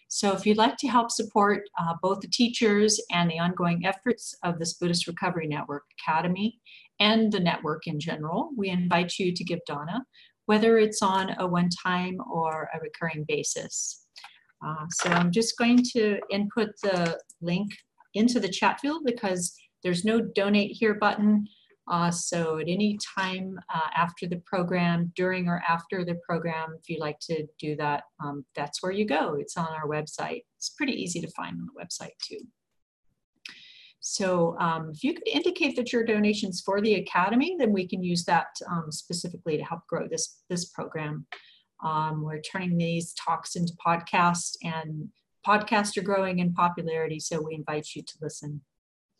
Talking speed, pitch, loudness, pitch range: 175 wpm, 180 Hz, -27 LUFS, 165-210 Hz